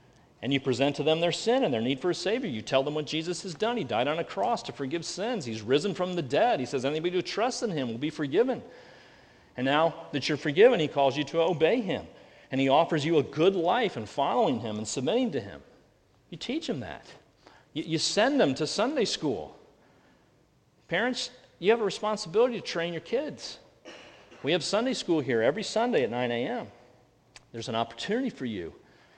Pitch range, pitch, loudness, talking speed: 140-200 Hz, 165 Hz, -28 LUFS, 210 wpm